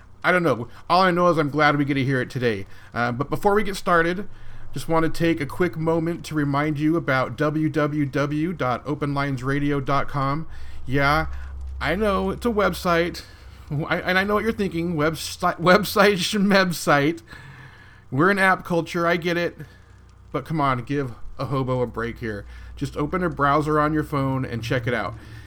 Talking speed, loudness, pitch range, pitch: 180 wpm, -22 LUFS, 130-170 Hz, 150 Hz